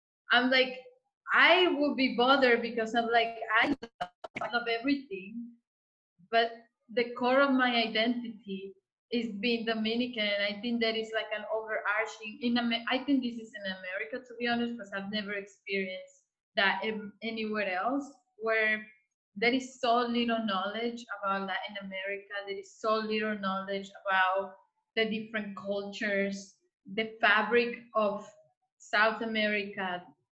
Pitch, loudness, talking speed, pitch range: 220 Hz, -30 LUFS, 135 wpm, 200-240 Hz